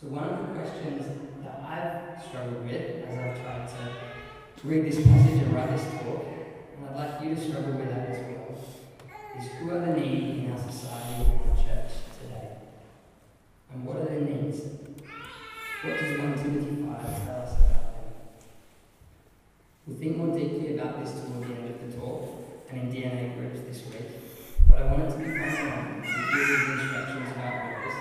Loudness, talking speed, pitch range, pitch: -29 LUFS, 180 wpm, 120-150 Hz, 130 Hz